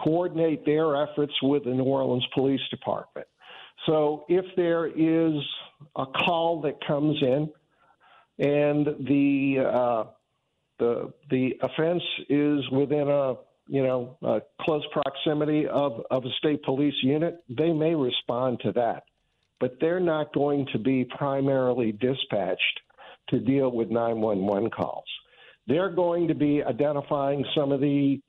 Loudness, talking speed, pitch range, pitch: -26 LUFS, 135 wpm, 130-155 Hz, 140 Hz